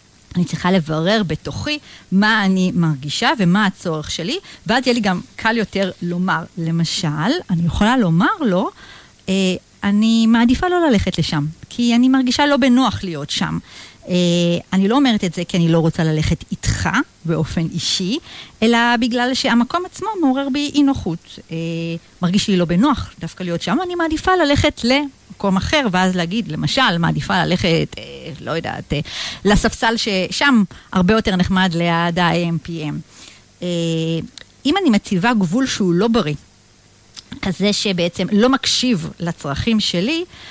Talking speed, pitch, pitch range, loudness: 150 wpm, 185 Hz, 165-235 Hz, -17 LUFS